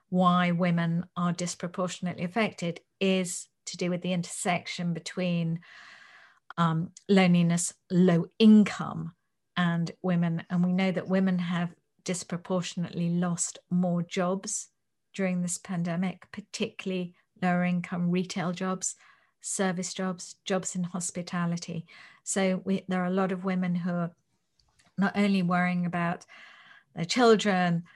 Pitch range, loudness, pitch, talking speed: 175-190 Hz, -28 LUFS, 180 Hz, 120 wpm